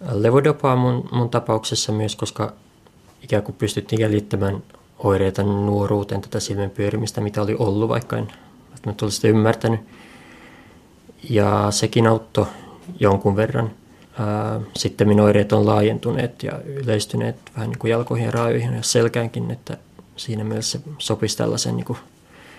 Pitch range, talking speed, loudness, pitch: 105-115 Hz, 140 wpm, -21 LUFS, 110 Hz